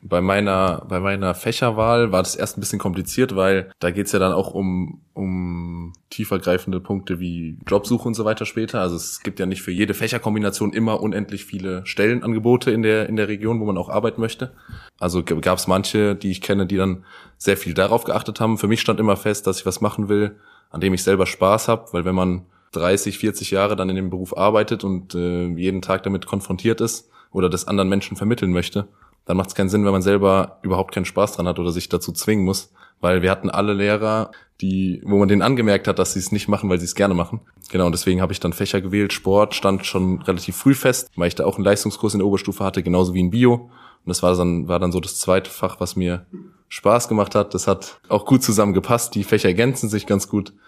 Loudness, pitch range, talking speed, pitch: -20 LUFS, 95-105 Hz, 235 wpm, 100 Hz